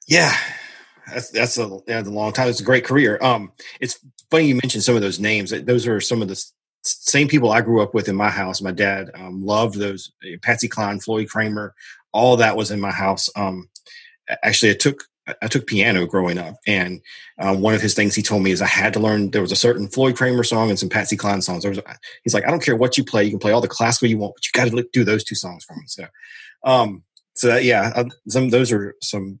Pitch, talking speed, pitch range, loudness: 110 Hz, 250 wpm, 100-120 Hz, -19 LUFS